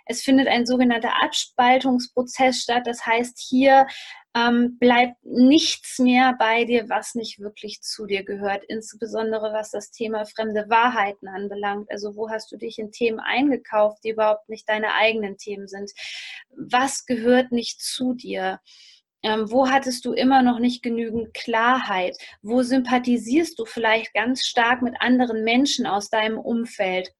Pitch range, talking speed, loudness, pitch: 215-250 Hz, 150 wpm, -21 LUFS, 235 Hz